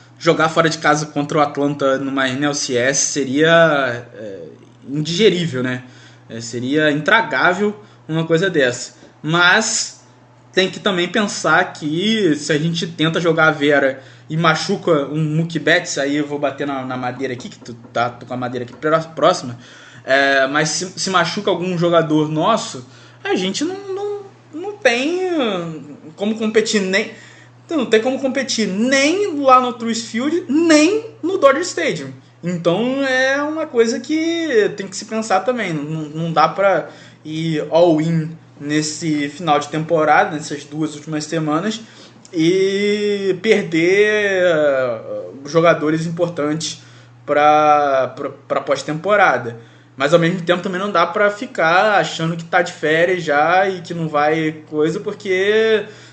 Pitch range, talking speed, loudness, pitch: 145-205 Hz, 145 wpm, -17 LUFS, 165 Hz